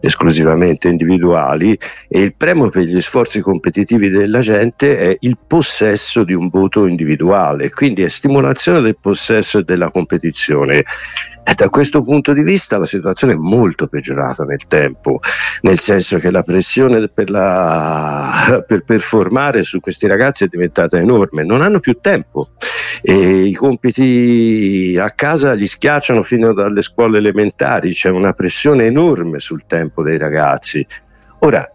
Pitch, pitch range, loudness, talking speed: 100 Hz, 90-120 Hz, -12 LUFS, 145 wpm